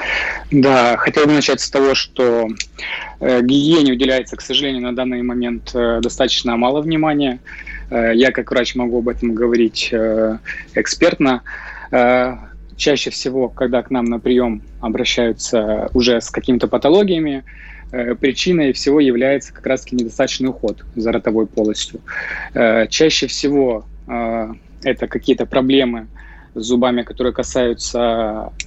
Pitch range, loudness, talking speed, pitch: 115-130 Hz, -16 LUFS, 115 wpm, 125 Hz